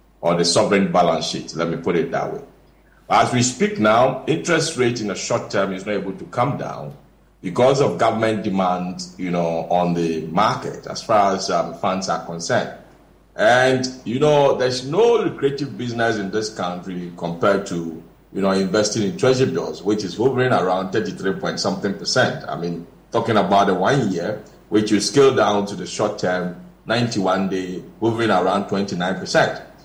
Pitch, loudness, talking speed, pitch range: 100 Hz, -20 LUFS, 180 wpm, 90-125 Hz